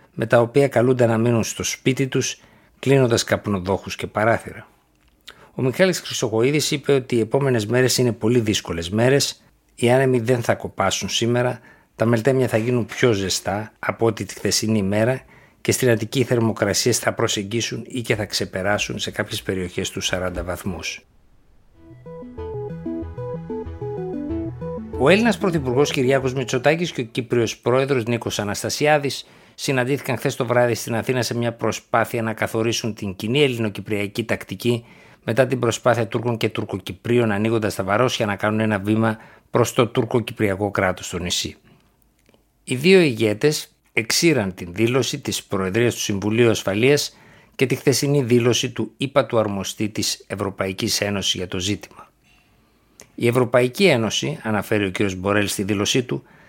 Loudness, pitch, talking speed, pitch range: -21 LUFS, 115 Hz, 150 wpm, 105-130 Hz